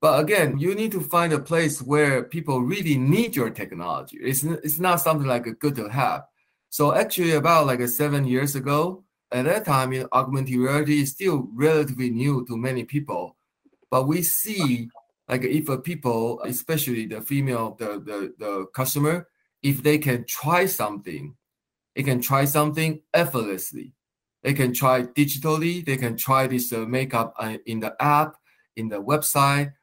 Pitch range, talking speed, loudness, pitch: 125-155 Hz, 170 wpm, -23 LUFS, 135 Hz